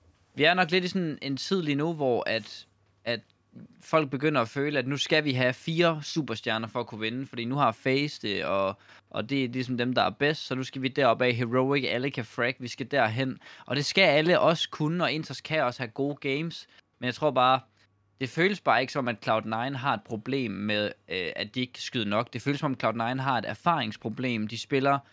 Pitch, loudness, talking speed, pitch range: 130 Hz, -28 LUFS, 235 wpm, 115-145 Hz